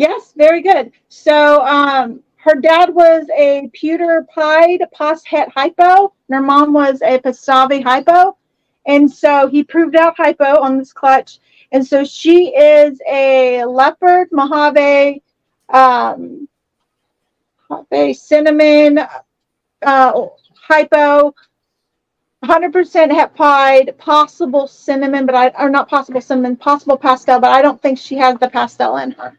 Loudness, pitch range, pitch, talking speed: -11 LUFS, 265-310 Hz, 285 Hz, 130 wpm